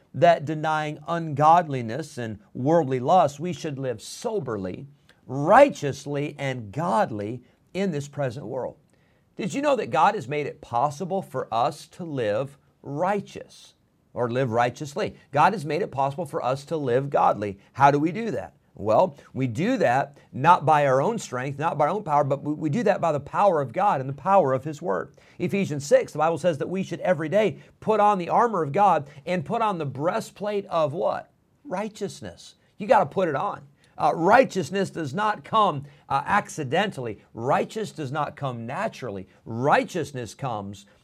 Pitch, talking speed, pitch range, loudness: 150 Hz, 180 wpm, 135-180 Hz, -24 LUFS